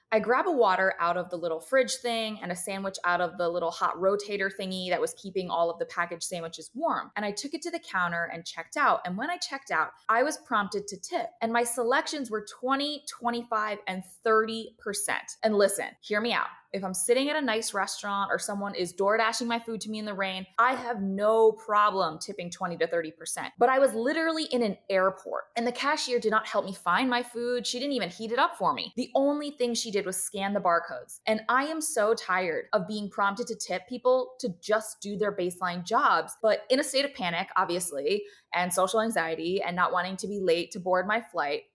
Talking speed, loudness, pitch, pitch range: 230 wpm, -28 LUFS, 215 Hz, 185-245 Hz